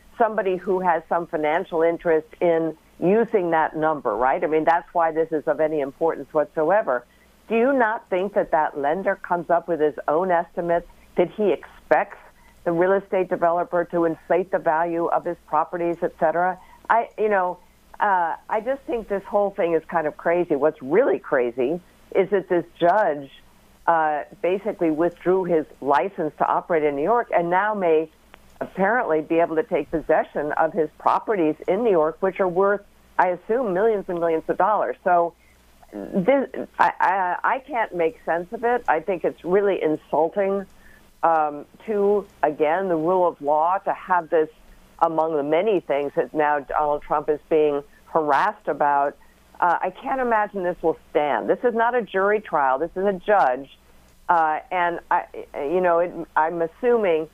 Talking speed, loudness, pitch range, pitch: 175 wpm, -22 LUFS, 155-195 Hz, 170 Hz